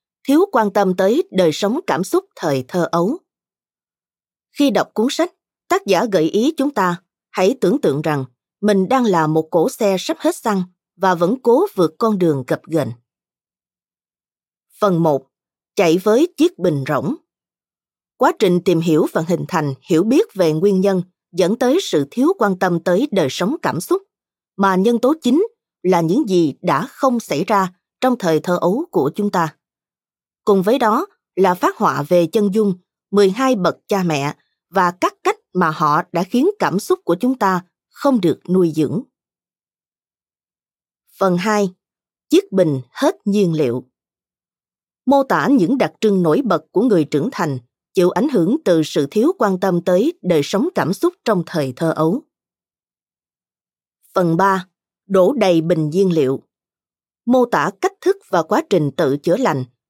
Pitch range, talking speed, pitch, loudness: 165-240 Hz, 170 wpm, 185 Hz, -17 LUFS